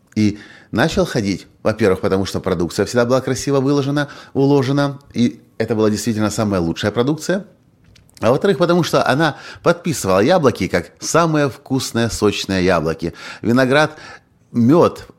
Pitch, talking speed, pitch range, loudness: 120 Hz, 130 wpm, 100-145 Hz, -17 LUFS